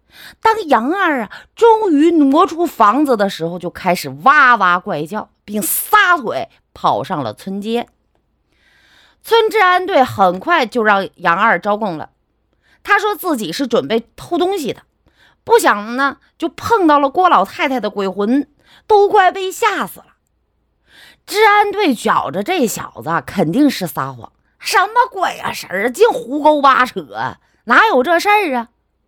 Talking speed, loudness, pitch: 210 characters per minute, -14 LUFS, 285 Hz